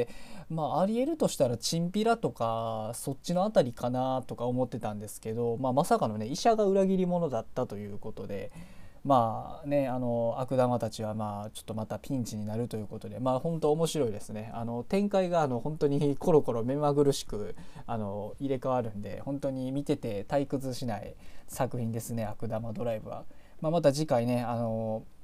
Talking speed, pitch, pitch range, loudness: 380 characters per minute, 125 Hz, 110-150 Hz, -31 LUFS